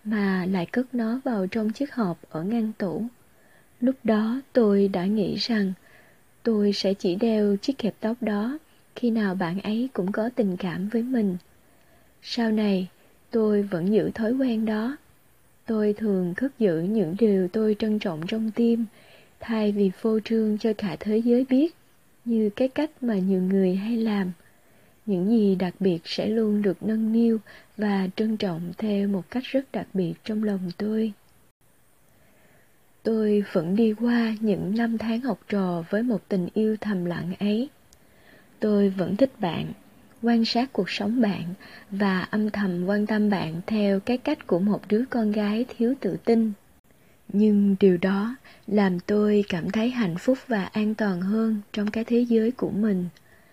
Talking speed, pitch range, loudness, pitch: 170 wpm, 195-225 Hz, -25 LUFS, 215 Hz